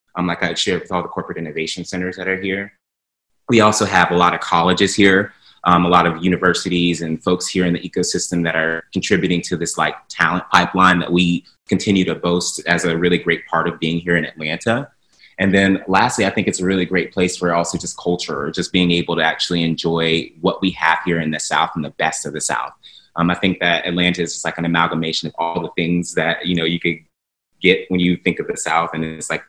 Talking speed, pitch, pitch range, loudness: 240 wpm, 85 Hz, 85-90 Hz, -18 LUFS